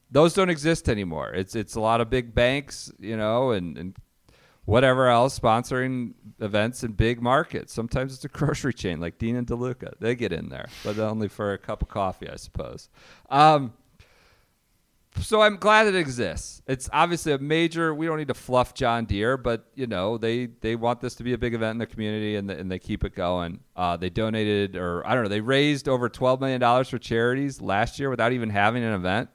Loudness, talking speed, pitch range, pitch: -24 LUFS, 215 wpm, 105-130 Hz, 120 Hz